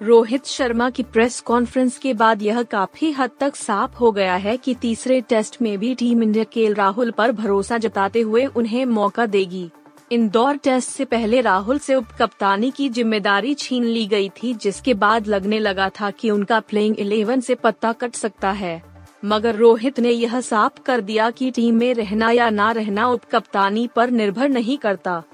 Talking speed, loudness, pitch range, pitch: 185 wpm, -19 LUFS, 210-250 Hz, 230 Hz